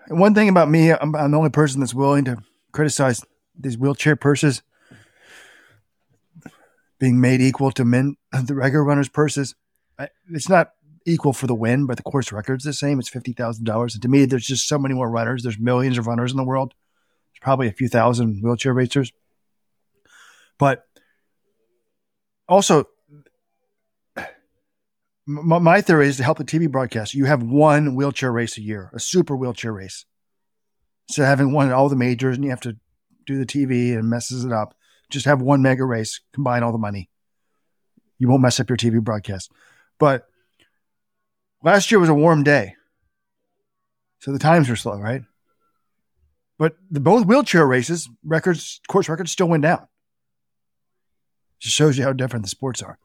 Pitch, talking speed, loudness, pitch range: 135 Hz, 170 wpm, -19 LUFS, 120-150 Hz